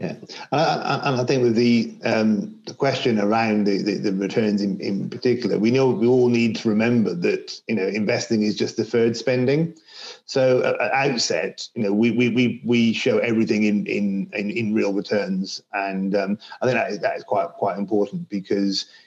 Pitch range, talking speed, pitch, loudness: 105-125 Hz, 200 wpm, 115 Hz, -21 LUFS